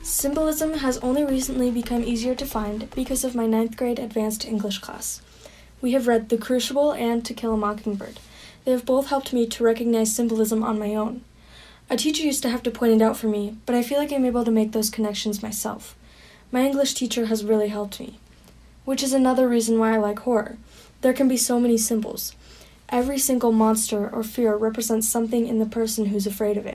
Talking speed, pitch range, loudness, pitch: 215 wpm, 220-255 Hz, -23 LUFS, 235 Hz